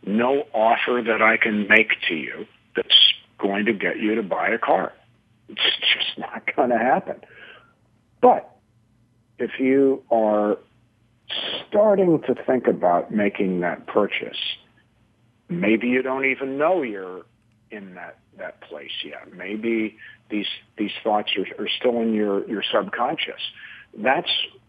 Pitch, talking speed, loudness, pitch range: 115 Hz, 140 wpm, -21 LUFS, 105-125 Hz